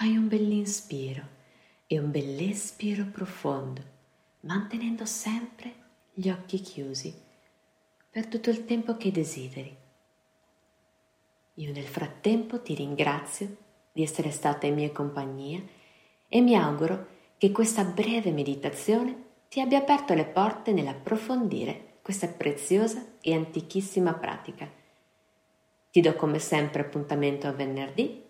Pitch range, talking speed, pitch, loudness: 145-220 Hz, 115 wpm, 180 Hz, -29 LUFS